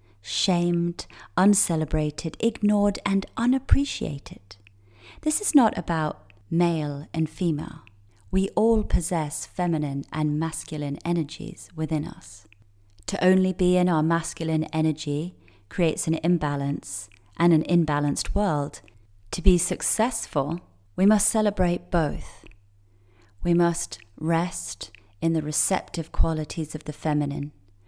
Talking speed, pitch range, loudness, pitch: 110 wpm, 115-180 Hz, -25 LUFS, 160 Hz